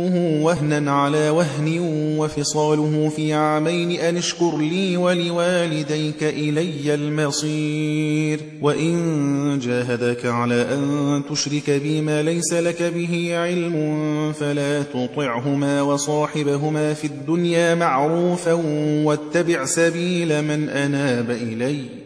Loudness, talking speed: -21 LUFS, 95 wpm